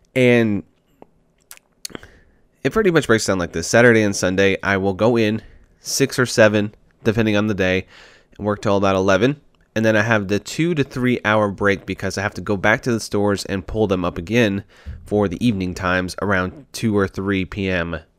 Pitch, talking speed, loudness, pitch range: 100 Hz, 200 wpm, -19 LUFS, 95-115 Hz